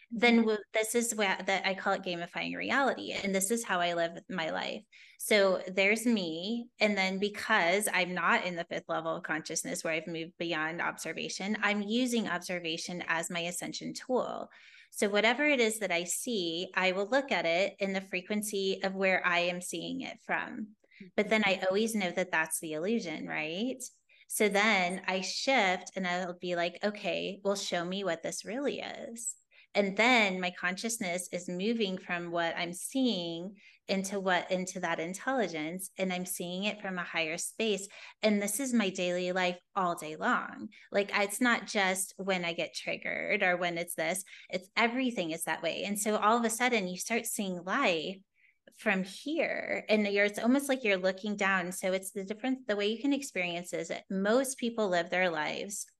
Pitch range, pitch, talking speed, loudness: 180-215 Hz, 195 Hz, 190 wpm, -31 LUFS